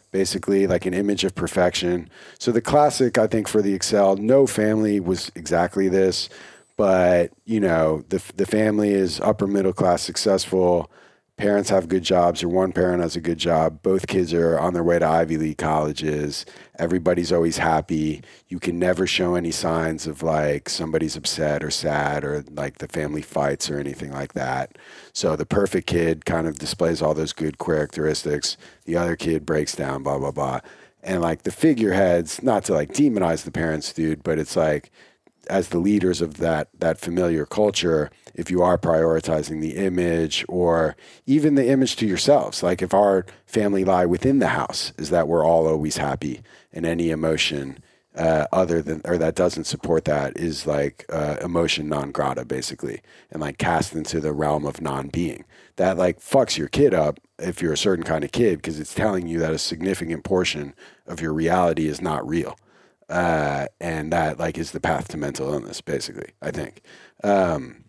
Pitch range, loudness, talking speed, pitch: 80-95 Hz, -22 LUFS, 185 wpm, 85 Hz